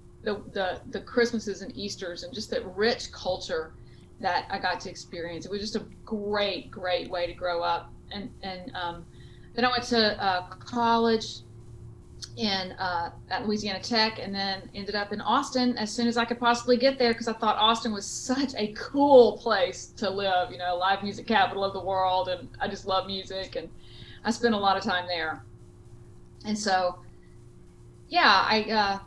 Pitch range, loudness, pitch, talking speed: 180-230 Hz, -27 LUFS, 200 Hz, 185 wpm